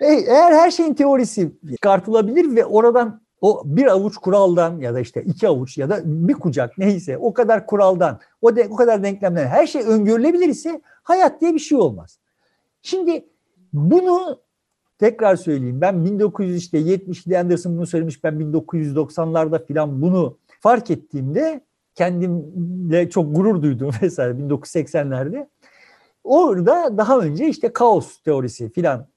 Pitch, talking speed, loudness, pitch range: 185 Hz, 135 wpm, -18 LUFS, 160-240 Hz